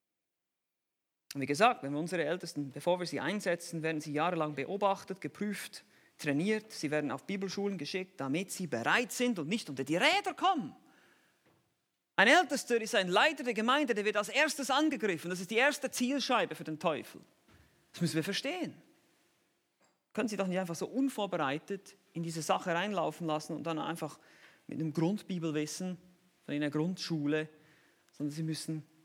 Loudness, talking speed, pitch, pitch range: -33 LUFS, 165 wpm, 180 Hz, 155-215 Hz